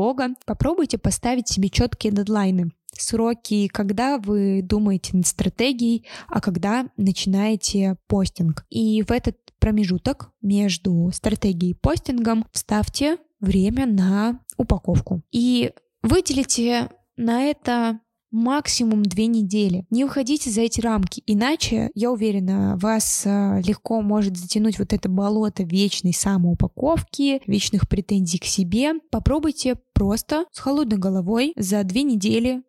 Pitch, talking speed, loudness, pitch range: 215 Hz, 115 wpm, -21 LUFS, 195-240 Hz